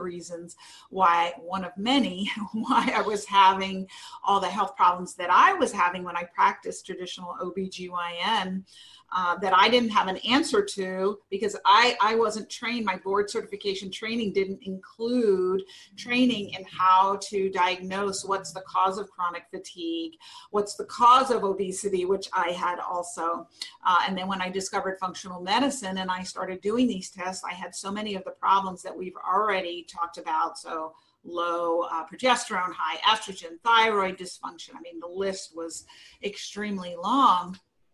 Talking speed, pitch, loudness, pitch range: 160 wpm, 190 Hz, -26 LUFS, 180-210 Hz